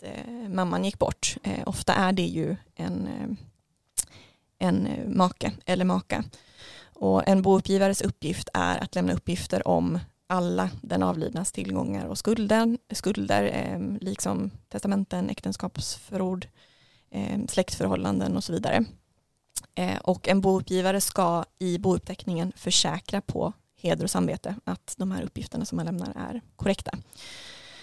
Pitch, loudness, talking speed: 185 Hz, -27 LUFS, 125 wpm